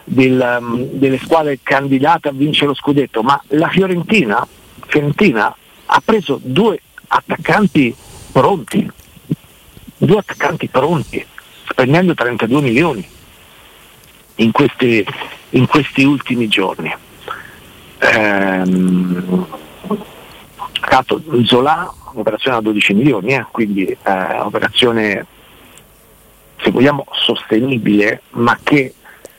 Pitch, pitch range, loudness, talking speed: 130 Hz, 110-145 Hz, -14 LUFS, 95 wpm